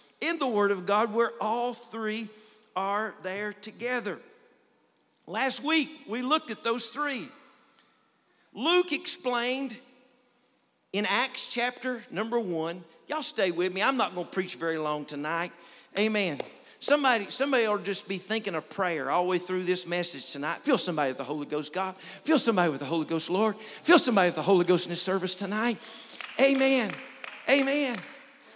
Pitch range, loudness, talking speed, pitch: 180-250 Hz, -28 LUFS, 170 wpm, 215 Hz